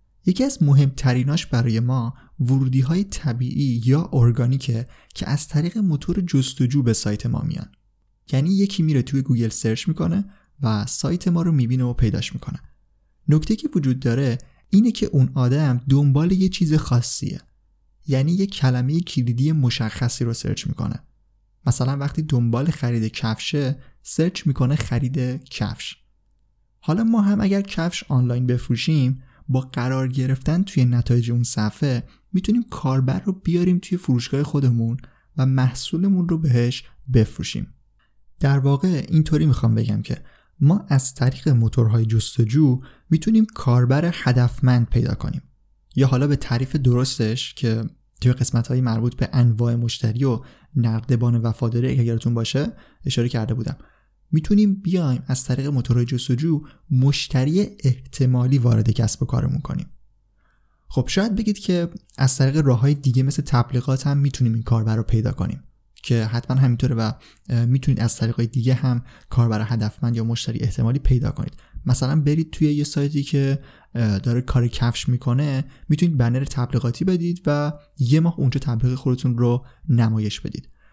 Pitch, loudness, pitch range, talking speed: 130 Hz, -21 LUFS, 120-150 Hz, 145 wpm